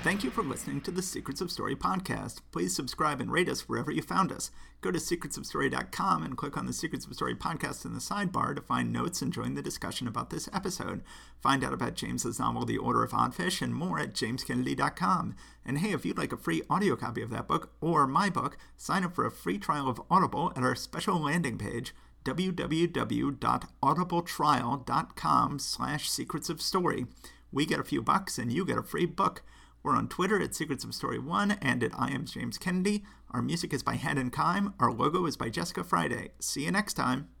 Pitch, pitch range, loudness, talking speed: 145 Hz, 125-180 Hz, -31 LUFS, 205 wpm